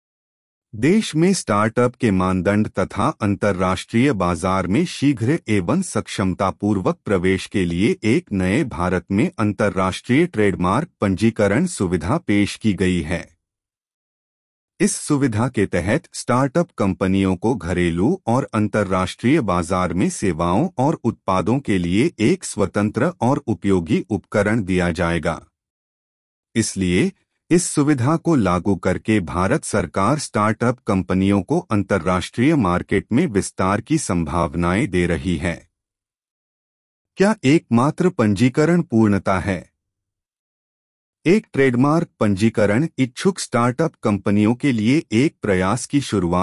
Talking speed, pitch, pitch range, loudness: 115 wpm, 105 Hz, 95-125 Hz, -19 LUFS